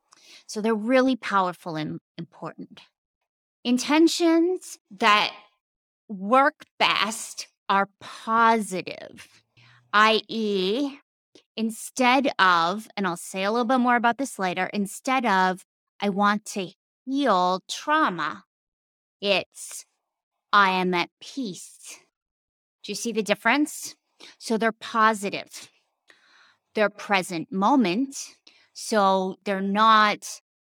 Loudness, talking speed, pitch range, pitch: -23 LUFS, 100 wpm, 190-250 Hz, 210 Hz